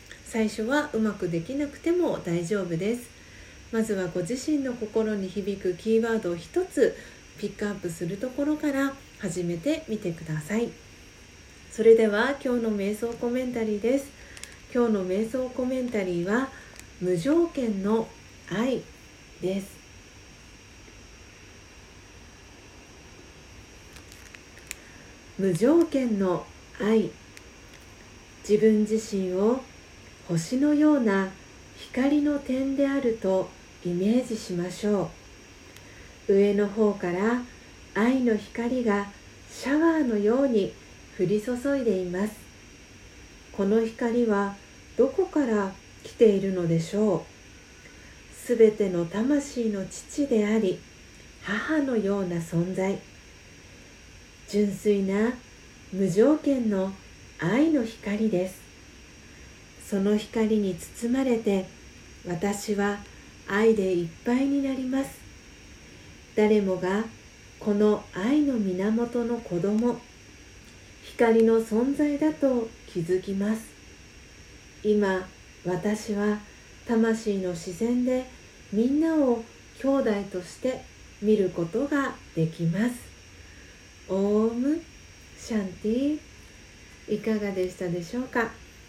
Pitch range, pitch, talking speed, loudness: 180-240 Hz, 210 Hz, 195 characters per minute, -26 LUFS